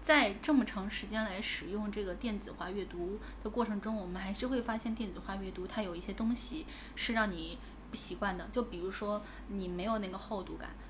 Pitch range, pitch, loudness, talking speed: 195-230 Hz, 210 Hz, -37 LUFS, 315 characters per minute